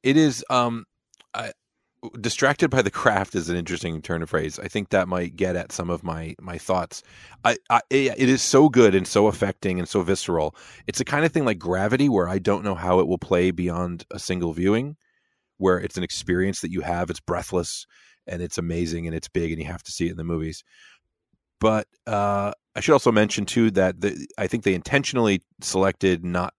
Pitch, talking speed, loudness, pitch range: 95 Hz, 215 wpm, -23 LUFS, 90-105 Hz